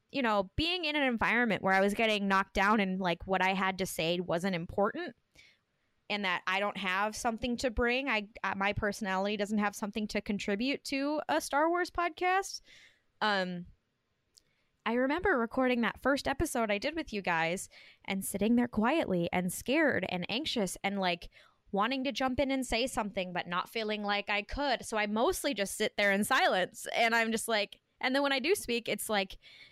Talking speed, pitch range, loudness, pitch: 200 wpm, 195-260 Hz, -31 LUFS, 215 Hz